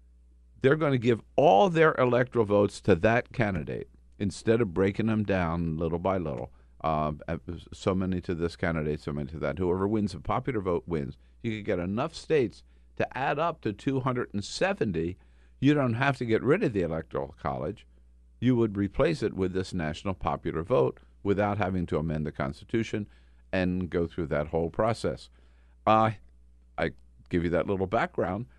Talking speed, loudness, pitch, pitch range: 175 wpm, -28 LUFS, 90 Hz, 70-105 Hz